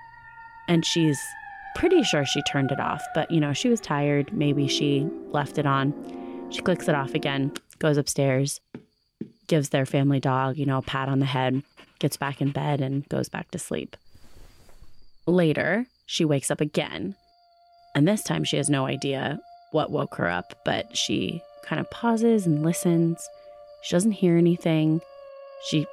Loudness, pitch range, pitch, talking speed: -25 LUFS, 140-185 Hz, 150 Hz, 170 wpm